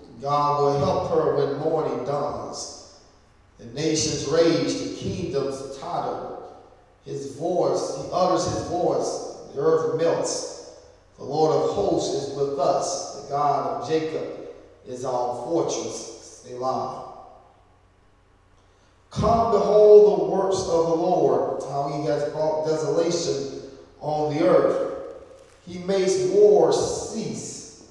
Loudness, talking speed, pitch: -23 LUFS, 120 wpm, 160 Hz